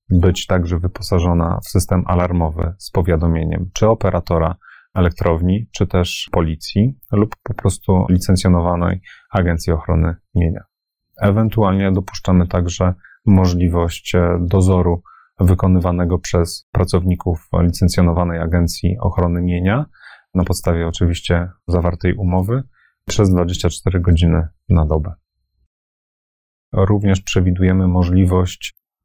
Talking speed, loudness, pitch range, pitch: 95 wpm, -17 LUFS, 85-95 Hz, 90 Hz